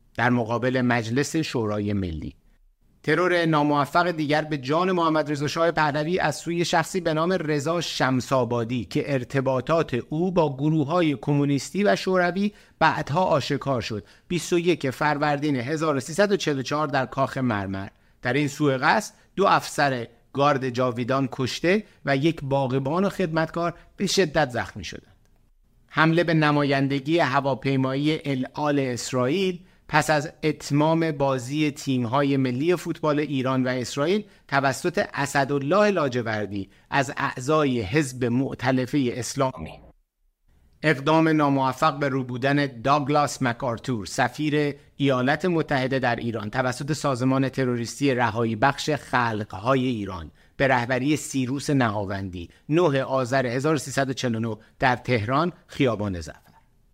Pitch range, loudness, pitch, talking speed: 125-155 Hz, -24 LUFS, 140 Hz, 115 wpm